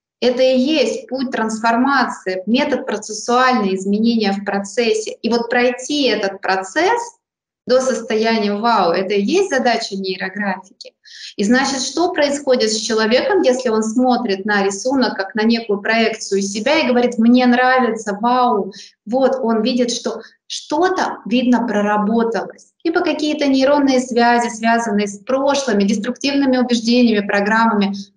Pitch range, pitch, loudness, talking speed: 215-260 Hz, 235 Hz, -16 LUFS, 130 wpm